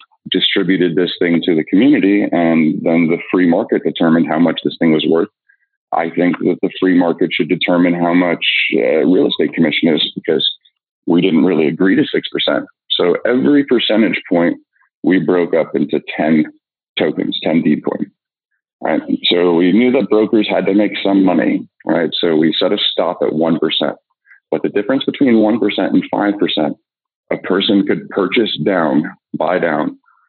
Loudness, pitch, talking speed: -14 LUFS, 105 Hz, 170 wpm